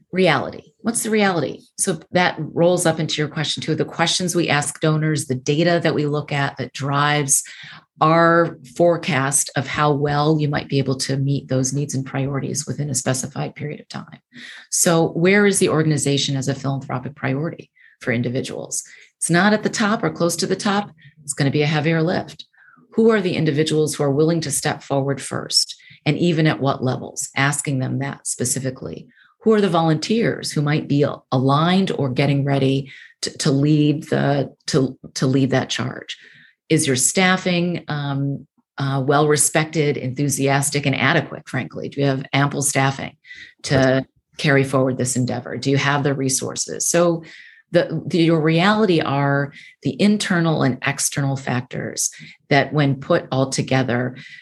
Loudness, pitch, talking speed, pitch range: -19 LUFS, 145 Hz, 170 wpm, 135-165 Hz